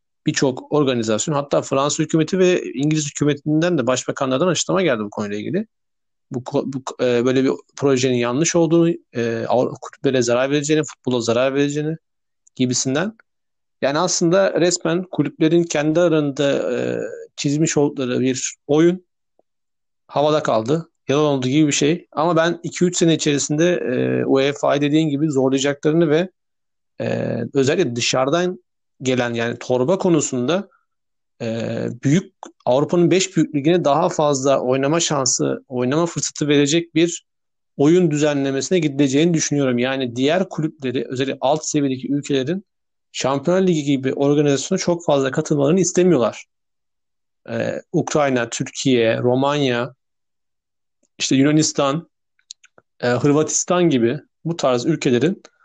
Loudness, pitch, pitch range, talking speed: -19 LUFS, 145 Hz, 130-165 Hz, 120 wpm